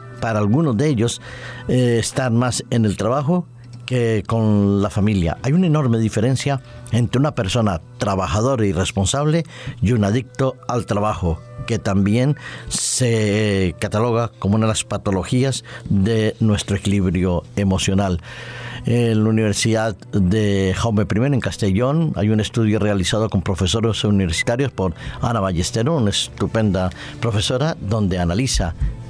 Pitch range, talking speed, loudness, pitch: 100-125 Hz, 135 wpm, -19 LUFS, 110 Hz